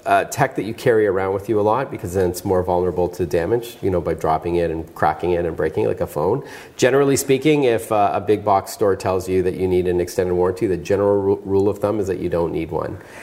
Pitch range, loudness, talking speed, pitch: 90-120 Hz, -20 LUFS, 270 wpm, 95 Hz